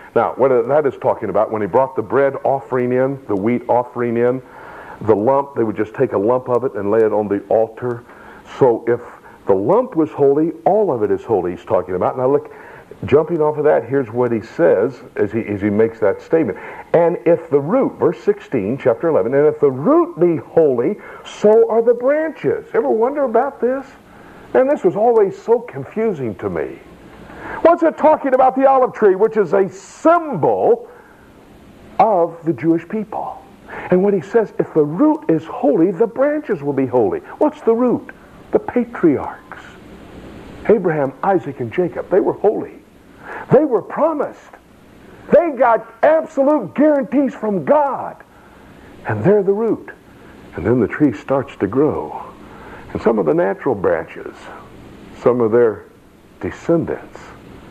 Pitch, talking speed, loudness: 210 Hz, 170 wpm, -17 LUFS